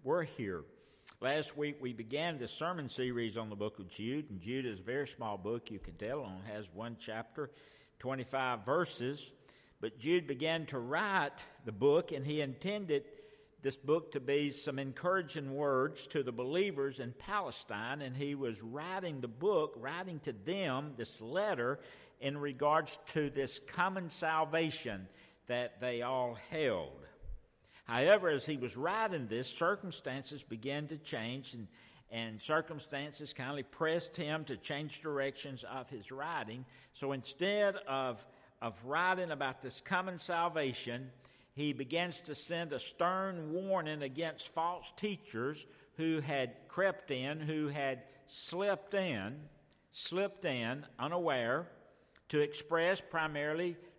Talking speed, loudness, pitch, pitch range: 145 wpm, -37 LUFS, 145 Hz, 130-165 Hz